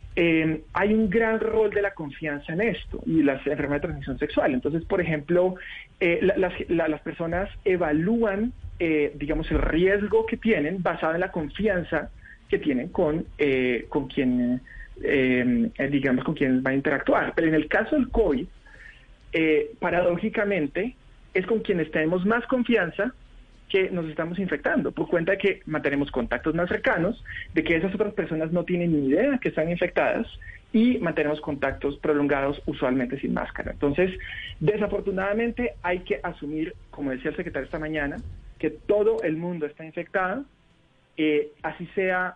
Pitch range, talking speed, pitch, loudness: 150-195 Hz, 160 wpm, 165 Hz, -25 LUFS